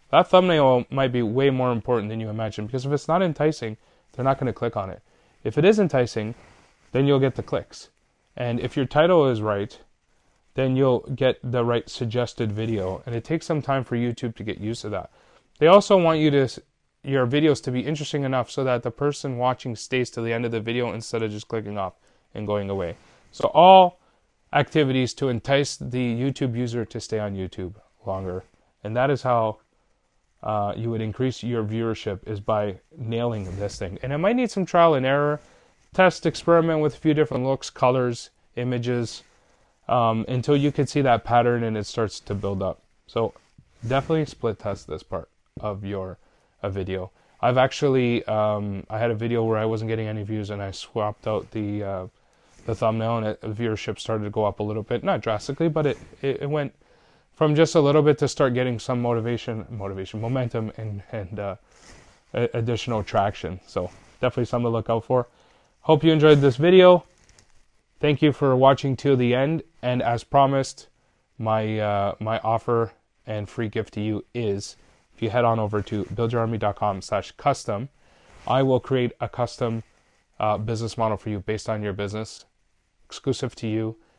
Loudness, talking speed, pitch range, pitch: -23 LUFS, 190 wpm, 110-135 Hz, 120 Hz